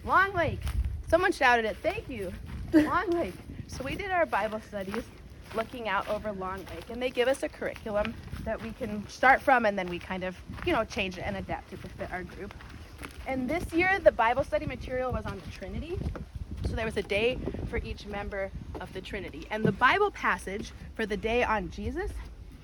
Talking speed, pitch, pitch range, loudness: 205 wpm, 235 Hz, 210-300 Hz, -30 LUFS